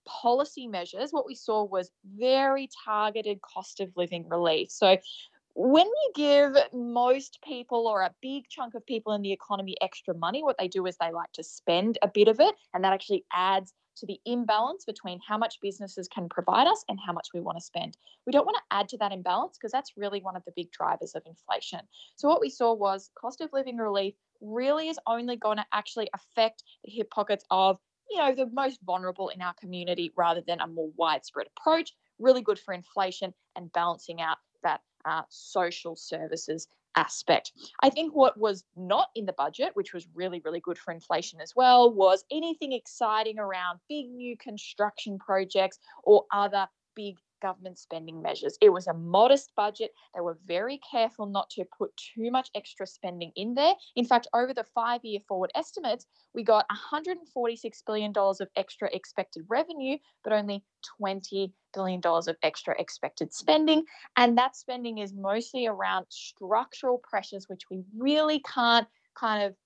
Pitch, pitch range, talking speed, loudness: 210 Hz, 185-250 Hz, 185 wpm, -28 LUFS